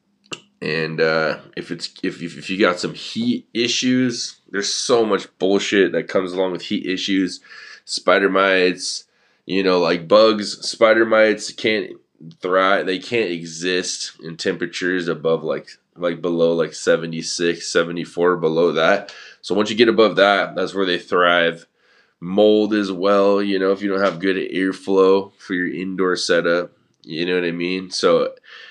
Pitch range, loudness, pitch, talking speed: 85-100 Hz, -19 LUFS, 95 Hz, 160 wpm